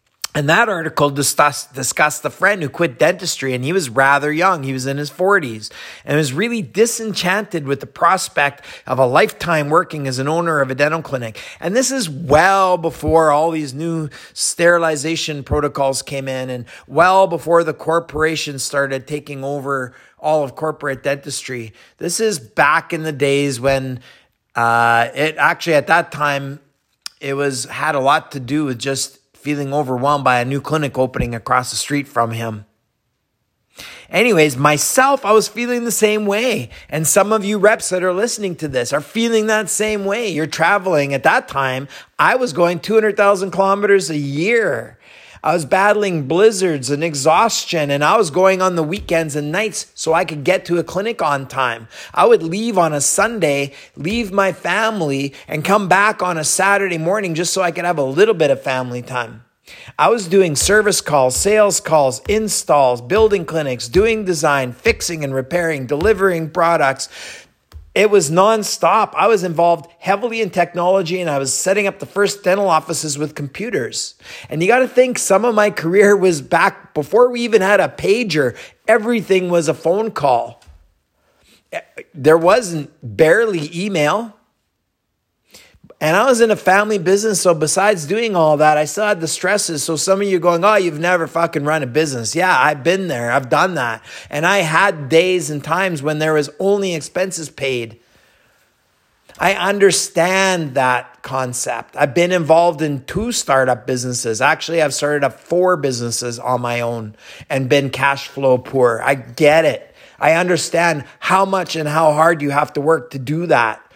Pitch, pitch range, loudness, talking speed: 160 Hz, 140-195 Hz, -16 LUFS, 175 wpm